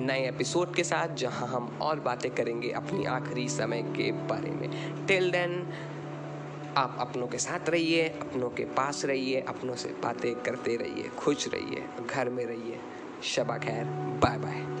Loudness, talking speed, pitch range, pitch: -31 LUFS, 160 wpm, 115-165 Hz, 130 Hz